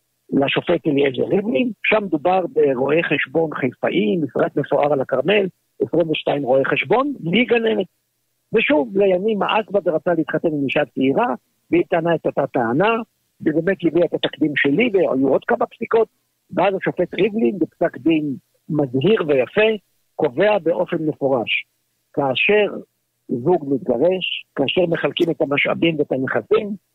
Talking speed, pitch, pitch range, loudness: 130 wpm, 170 Hz, 150-205 Hz, -19 LUFS